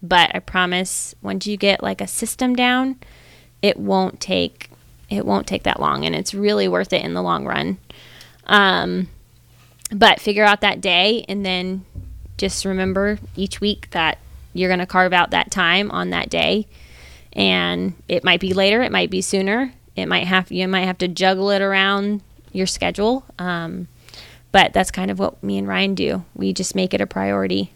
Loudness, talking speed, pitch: -19 LUFS, 190 wpm, 185 Hz